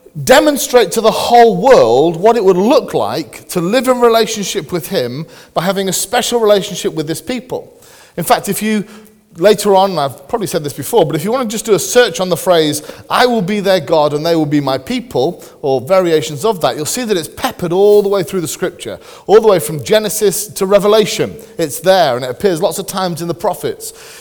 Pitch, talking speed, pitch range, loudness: 200 Hz, 230 wpm, 170-235 Hz, -13 LUFS